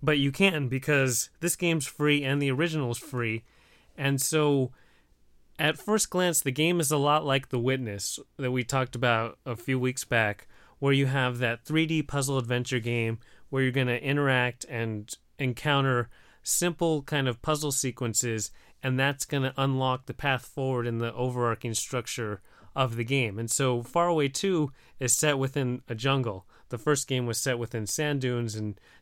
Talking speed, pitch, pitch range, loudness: 180 wpm, 130 Hz, 120-145 Hz, -28 LUFS